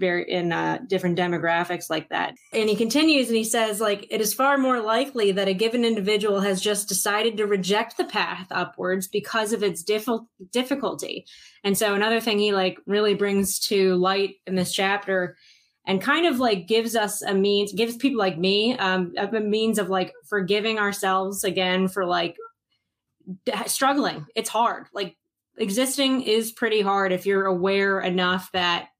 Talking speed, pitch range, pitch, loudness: 175 wpm, 190-225 Hz, 205 Hz, -23 LUFS